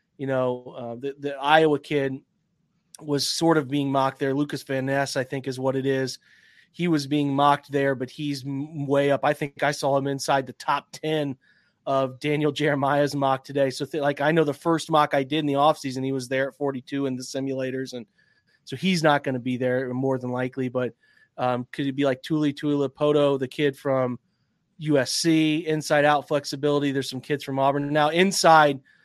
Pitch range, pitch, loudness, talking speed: 135-150 Hz, 140 Hz, -24 LUFS, 200 wpm